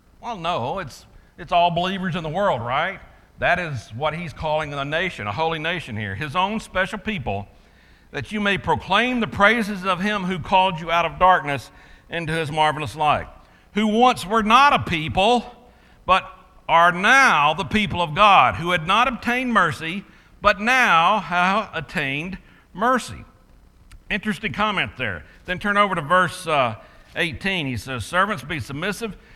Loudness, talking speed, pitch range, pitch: -20 LUFS, 165 wpm, 155-210 Hz, 180 Hz